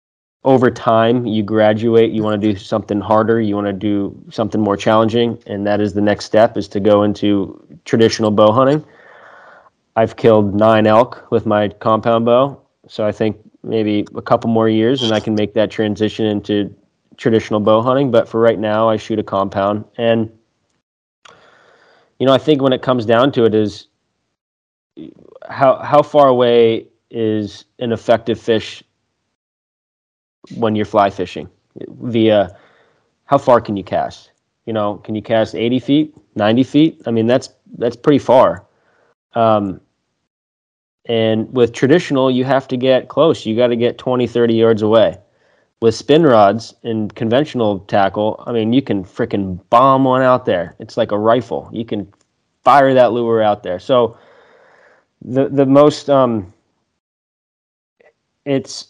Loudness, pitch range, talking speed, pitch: -15 LUFS, 105-125 Hz, 160 wpm, 110 Hz